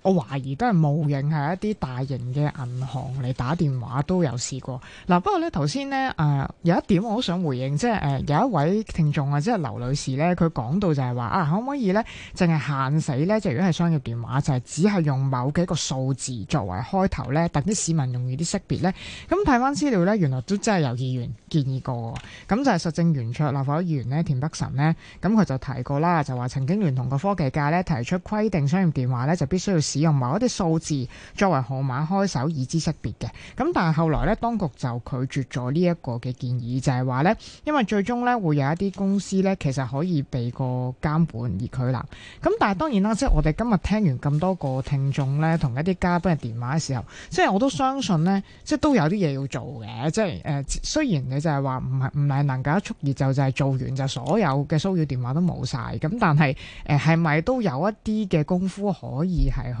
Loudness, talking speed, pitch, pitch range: -24 LUFS, 330 characters per minute, 150 Hz, 135-185 Hz